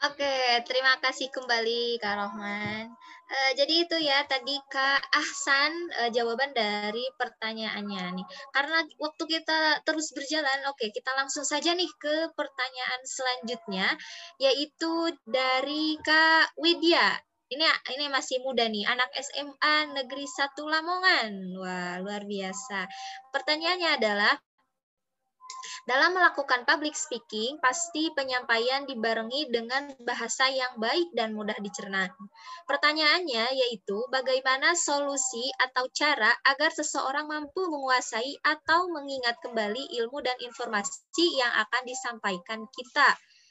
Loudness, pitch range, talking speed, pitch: -27 LUFS, 235-300 Hz, 120 wpm, 265 Hz